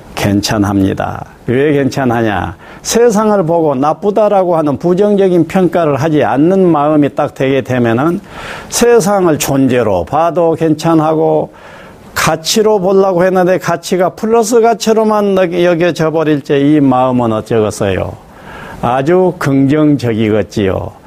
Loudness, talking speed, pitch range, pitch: -11 LUFS, 275 characters per minute, 135-185 Hz, 160 Hz